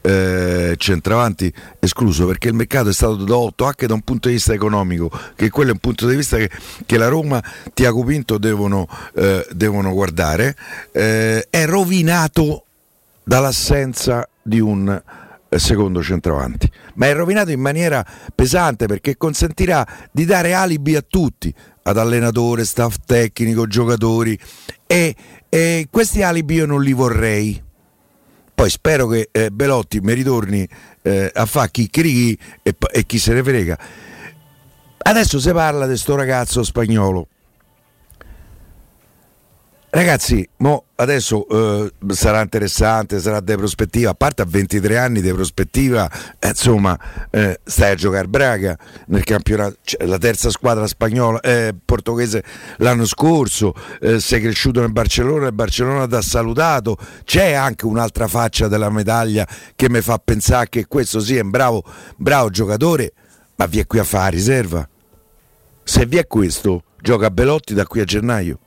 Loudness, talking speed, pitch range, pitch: -16 LUFS, 150 wpm, 105-130 Hz, 115 Hz